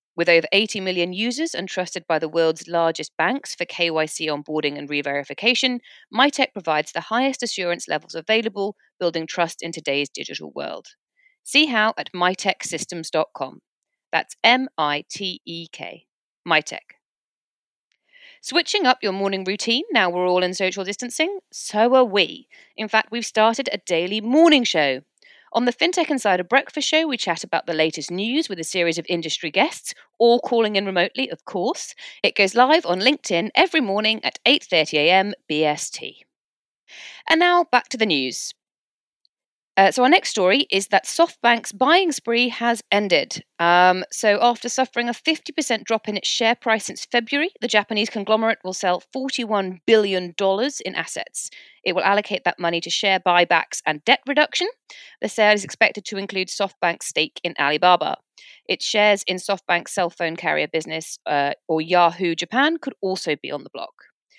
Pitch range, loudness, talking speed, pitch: 175-245 Hz, -20 LUFS, 165 wpm, 200 Hz